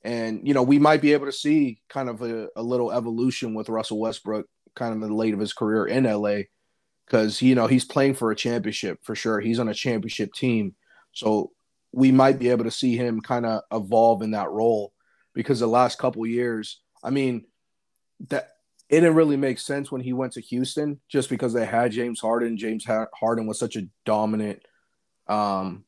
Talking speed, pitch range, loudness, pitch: 205 wpm, 110-130 Hz, -24 LUFS, 115 Hz